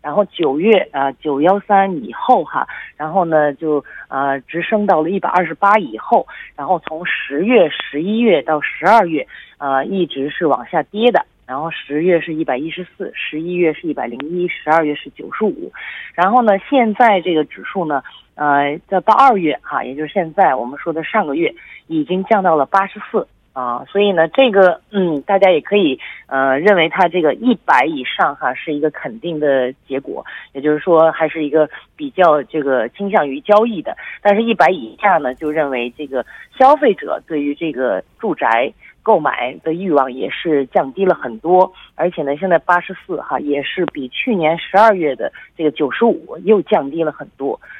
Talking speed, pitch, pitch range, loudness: 275 characters per minute, 165 Hz, 150-195 Hz, -16 LUFS